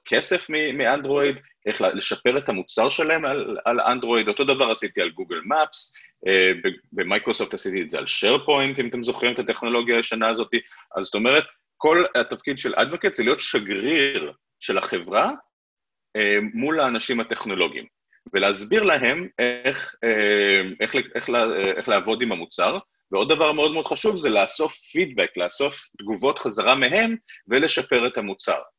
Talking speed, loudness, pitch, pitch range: 150 wpm, -22 LUFS, 135 Hz, 110-155 Hz